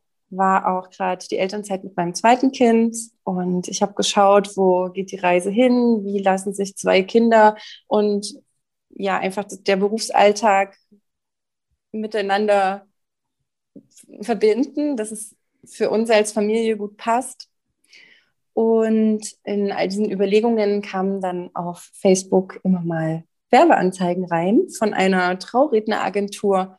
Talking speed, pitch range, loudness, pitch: 125 wpm, 190-220 Hz, -19 LUFS, 205 Hz